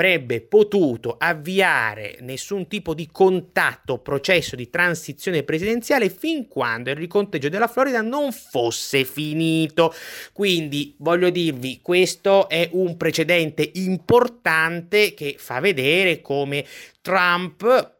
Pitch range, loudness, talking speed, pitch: 150-195 Hz, -20 LUFS, 110 wpm, 170 Hz